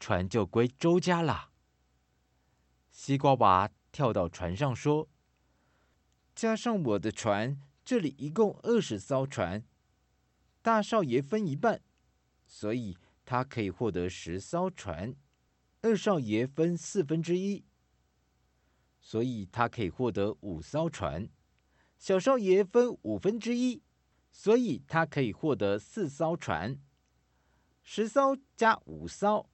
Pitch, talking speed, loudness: 115 Hz, 170 characters per minute, -30 LUFS